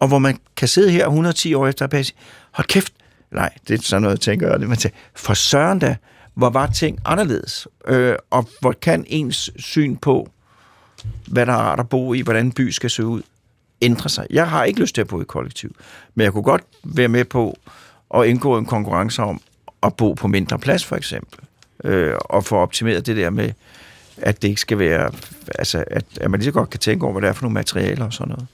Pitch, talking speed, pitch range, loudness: 120 Hz, 230 wpm, 105-130 Hz, -19 LUFS